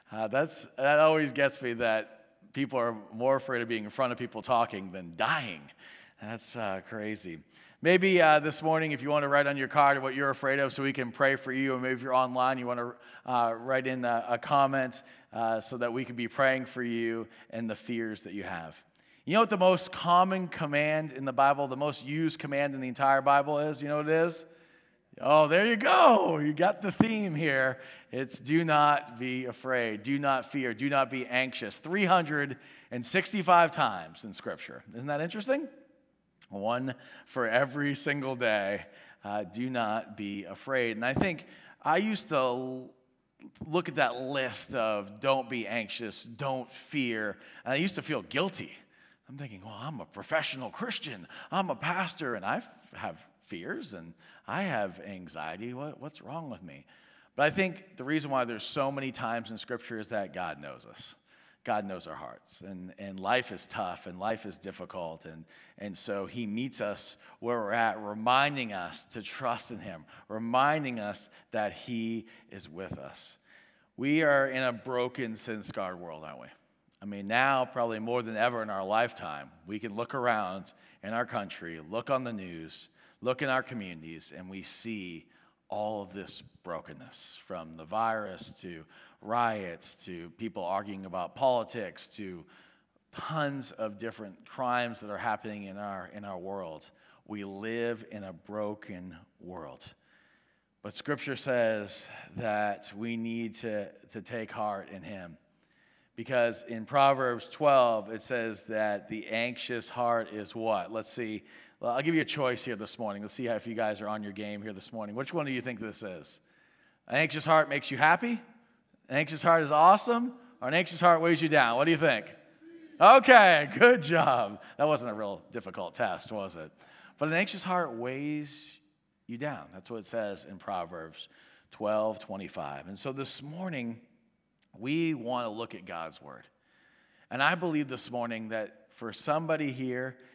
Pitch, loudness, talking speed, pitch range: 125 Hz, -30 LUFS, 180 wpm, 110-145 Hz